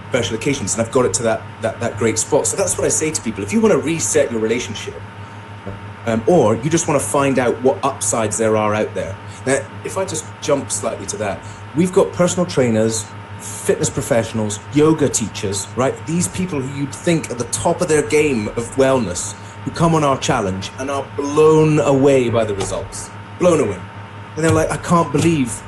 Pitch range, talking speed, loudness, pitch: 100-145 Hz, 210 wpm, -18 LUFS, 115 Hz